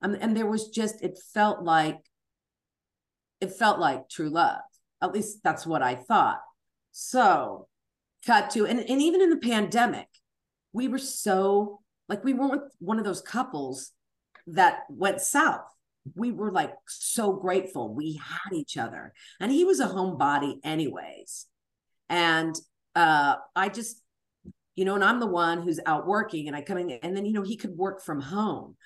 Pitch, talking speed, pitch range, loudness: 200 Hz, 175 wpm, 170-230 Hz, -26 LUFS